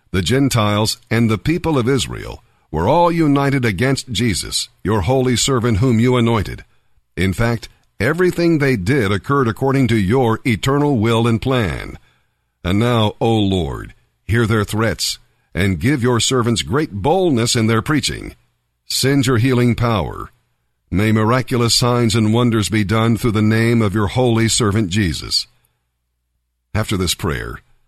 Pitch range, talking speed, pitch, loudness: 105-130 Hz, 150 wpm, 115 Hz, -16 LUFS